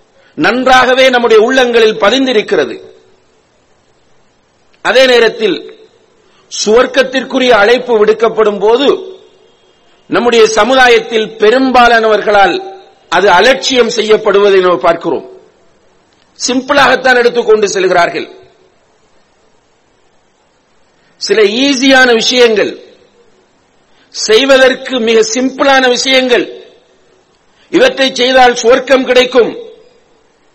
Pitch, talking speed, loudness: 255 Hz, 65 wpm, -8 LUFS